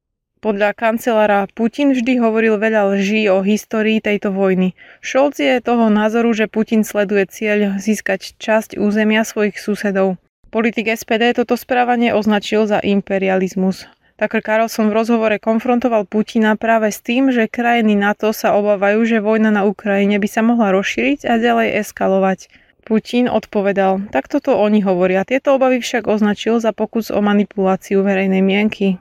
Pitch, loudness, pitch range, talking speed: 215 Hz, -16 LUFS, 200-230 Hz, 150 wpm